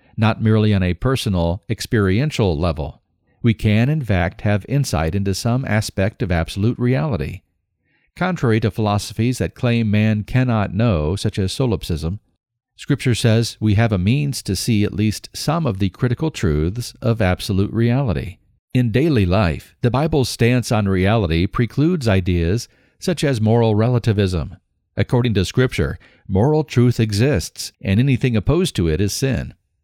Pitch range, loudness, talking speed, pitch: 95-125 Hz, -19 LUFS, 150 wpm, 110 Hz